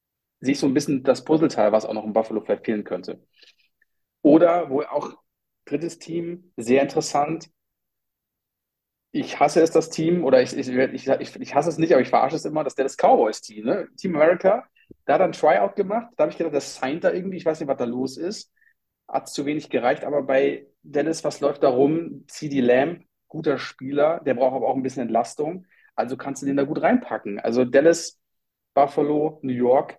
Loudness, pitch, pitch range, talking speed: -22 LUFS, 145 Hz, 130-165 Hz, 205 wpm